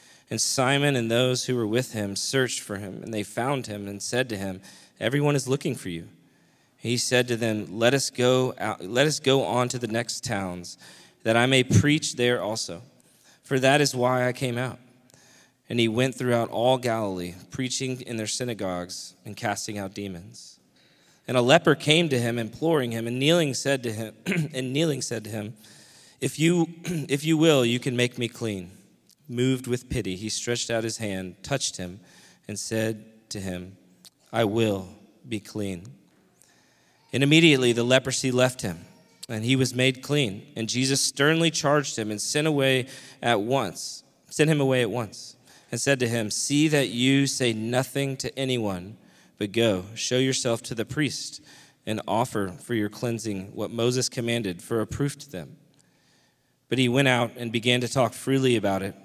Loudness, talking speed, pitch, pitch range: -25 LUFS, 185 wpm, 125 Hz, 110-135 Hz